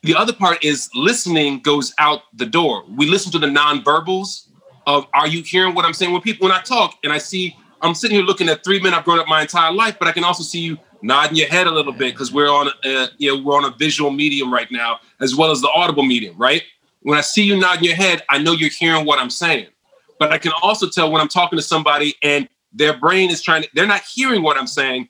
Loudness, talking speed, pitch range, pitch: -16 LUFS, 265 wpm, 145-180 Hz, 160 Hz